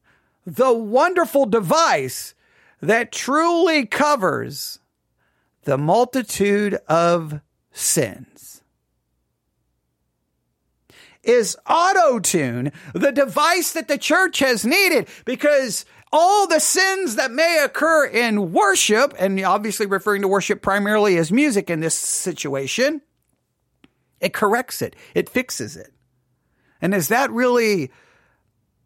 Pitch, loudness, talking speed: 230 Hz, -18 LUFS, 105 wpm